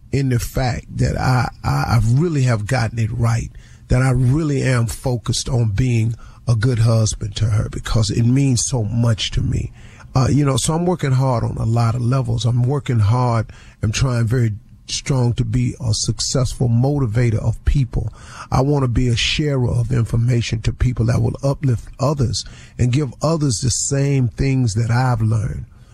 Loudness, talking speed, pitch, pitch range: -19 LUFS, 185 wpm, 120 Hz, 115-130 Hz